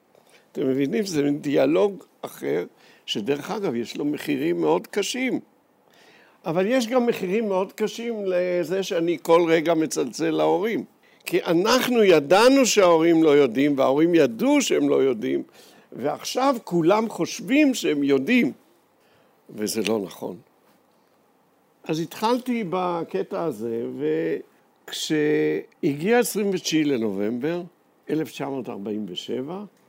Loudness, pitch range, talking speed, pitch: -22 LUFS, 150-235 Hz, 100 wpm, 180 Hz